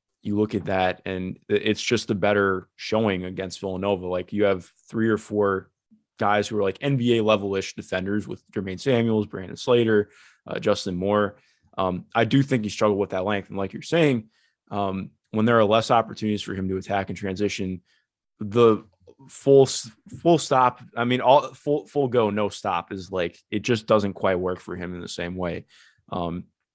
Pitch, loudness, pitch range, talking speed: 105 Hz, -24 LUFS, 95-115 Hz, 190 wpm